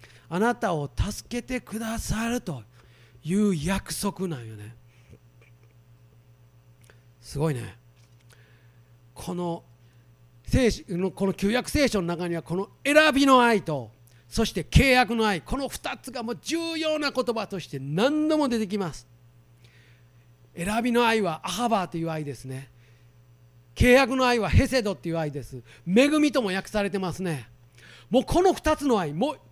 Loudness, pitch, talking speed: -25 LUFS, 170 Hz, 255 characters per minute